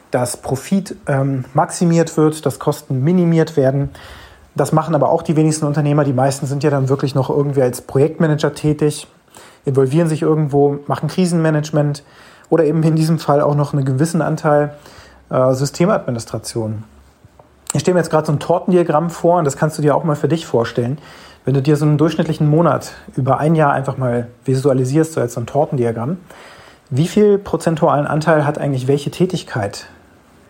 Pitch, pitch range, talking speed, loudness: 150 Hz, 135-160 Hz, 175 wpm, -16 LUFS